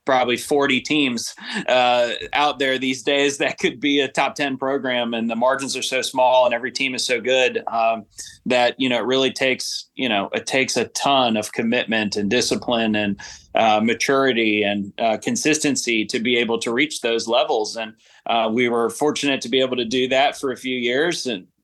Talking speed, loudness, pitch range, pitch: 200 wpm, -20 LUFS, 115-135 Hz, 125 Hz